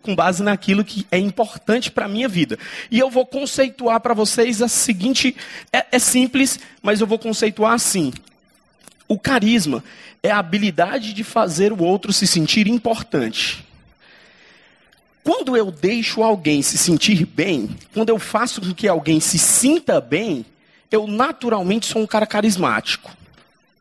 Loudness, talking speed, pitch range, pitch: -18 LUFS, 150 wpm, 195-245 Hz, 220 Hz